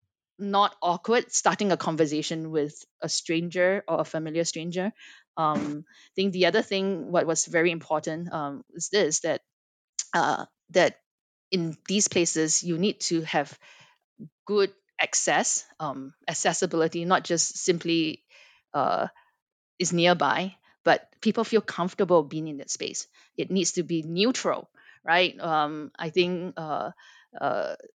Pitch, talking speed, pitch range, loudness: 170 Hz, 135 wpm, 160-195 Hz, -26 LUFS